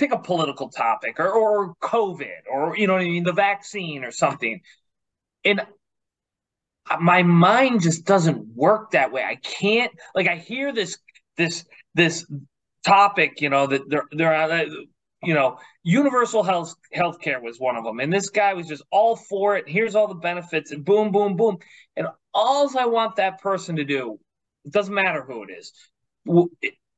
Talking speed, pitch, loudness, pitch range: 180 wpm, 180 Hz, -21 LUFS, 160-210 Hz